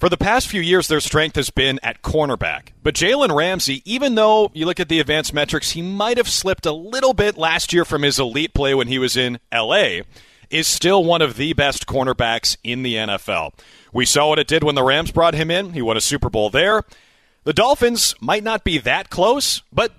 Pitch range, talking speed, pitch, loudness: 135-185 Hz, 225 wpm, 155 Hz, -18 LUFS